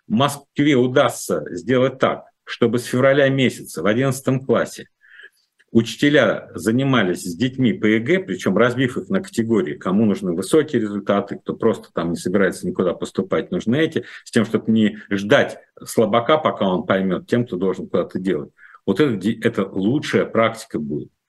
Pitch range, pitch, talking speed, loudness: 110-135 Hz, 120 Hz, 155 wpm, -20 LUFS